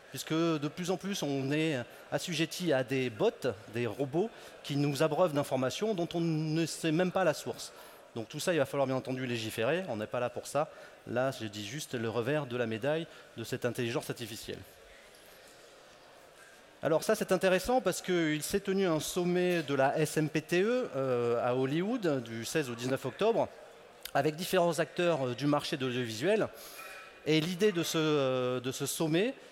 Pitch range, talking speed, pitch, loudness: 130-175 Hz, 175 wpm, 150 Hz, -32 LUFS